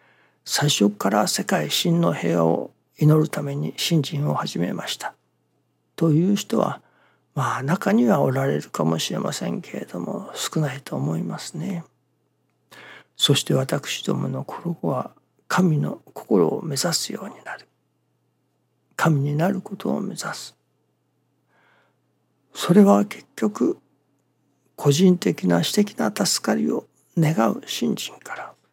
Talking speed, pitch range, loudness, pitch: 230 characters per minute, 130-175 Hz, -22 LUFS, 145 Hz